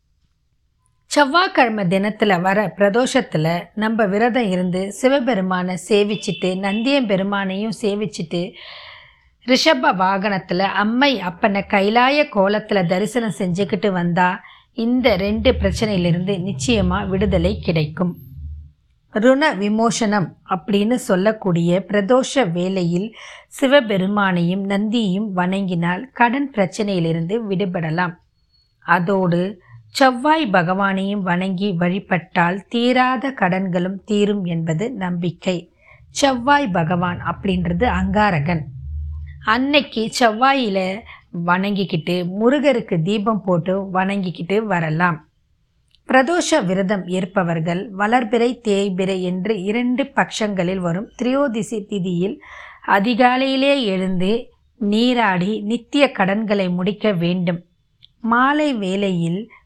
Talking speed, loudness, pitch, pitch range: 80 wpm, -18 LUFS, 200 Hz, 180-230 Hz